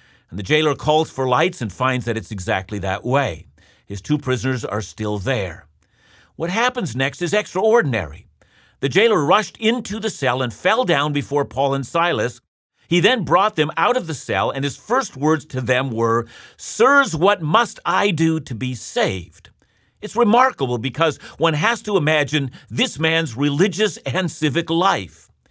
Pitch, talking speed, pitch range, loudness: 140 Hz, 170 wpm, 115-170 Hz, -19 LUFS